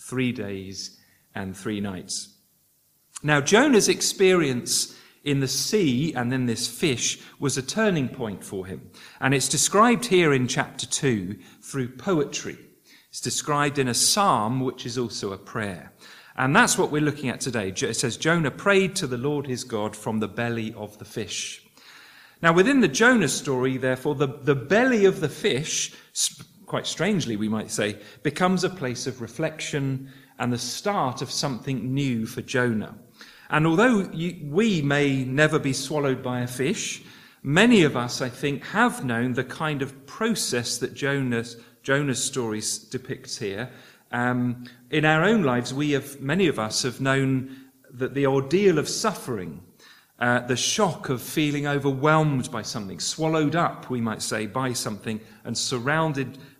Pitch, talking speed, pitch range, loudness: 135 Hz, 165 wpm, 120-155 Hz, -24 LUFS